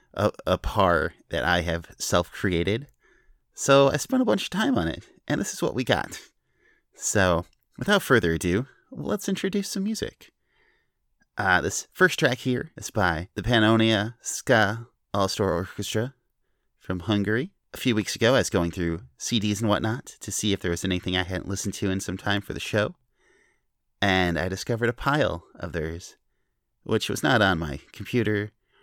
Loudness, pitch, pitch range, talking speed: -25 LUFS, 105 Hz, 90-120 Hz, 175 wpm